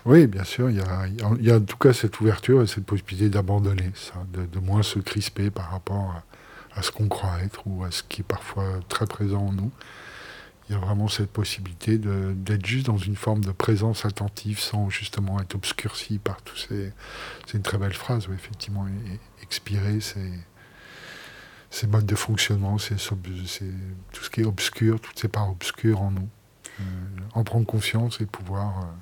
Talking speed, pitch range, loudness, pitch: 200 wpm, 95-110 Hz, -26 LUFS, 100 Hz